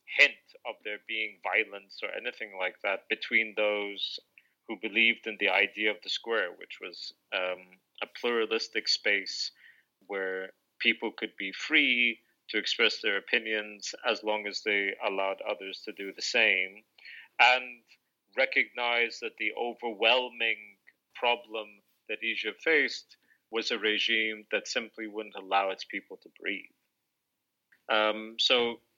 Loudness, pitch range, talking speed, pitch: -29 LUFS, 100-115 Hz, 135 wpm, 110 Hz